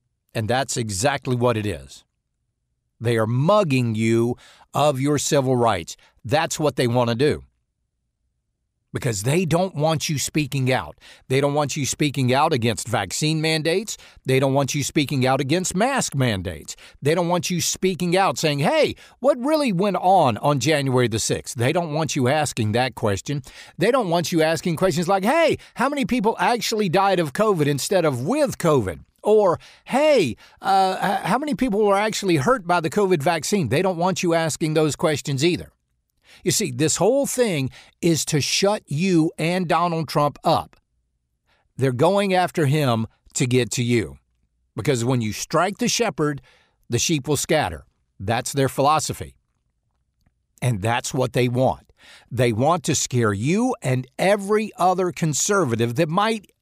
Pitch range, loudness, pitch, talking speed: 125-180 Hz, -21 LUFS, 150 Hz, 165 wpm